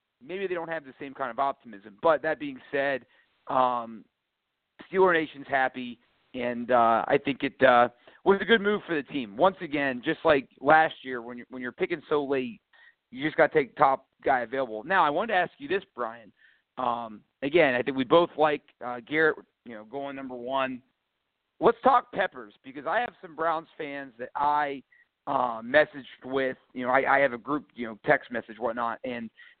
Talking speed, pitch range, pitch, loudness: 205 wpm, 125-160 Hz, 140 Hz, -27 LUFS